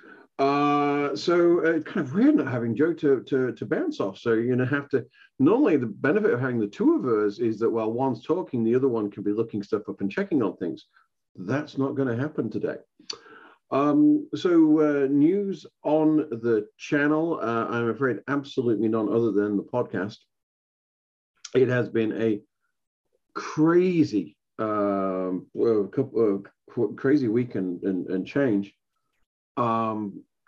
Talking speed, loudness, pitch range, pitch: 160 wpm, -25 LUFS, 105-150 Hz, 125 Hz